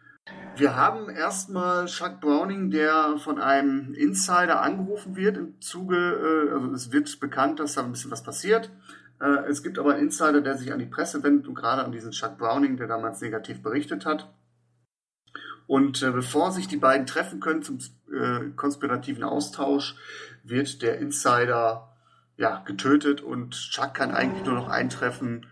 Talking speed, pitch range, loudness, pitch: 160 wpm, 125-155 Hz, -25 LUFS, 140 Hz